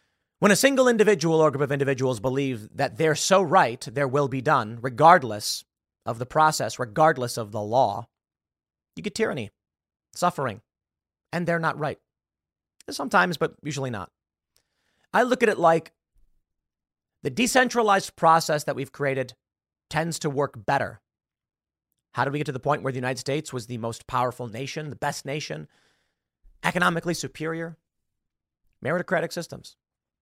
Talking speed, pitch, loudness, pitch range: 150 wpm, 145 Hz, -24 LUFS, 125-165 Hz